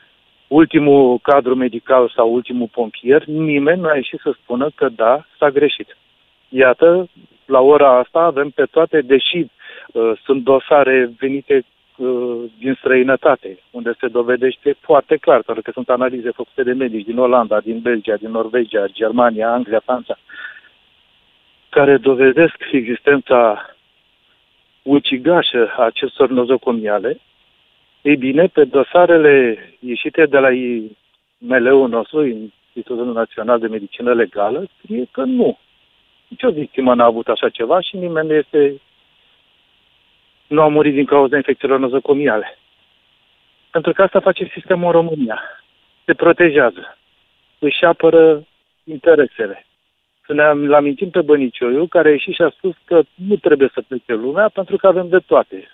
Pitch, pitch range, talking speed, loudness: 140 Hz, 125-165 Hz, 135 wpm, -15 LUFS